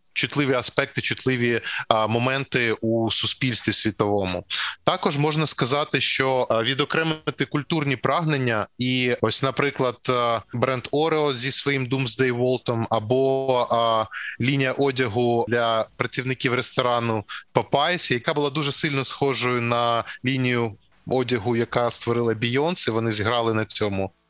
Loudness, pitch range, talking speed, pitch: -22 LUFS, 115-140 Hz, 125 wpm, 125 Hz